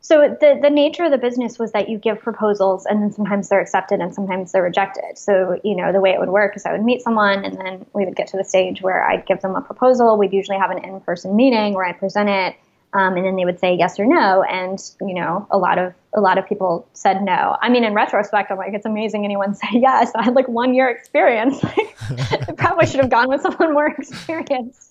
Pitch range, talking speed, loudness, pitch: 190-245 Hz, 255 wpm, -18 LUFS, 205 Hz